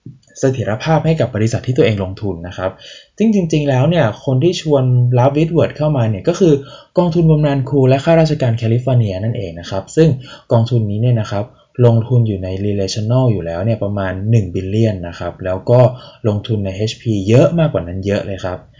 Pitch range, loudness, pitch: 100-140 Hz, -15 LUFS, 120 Hz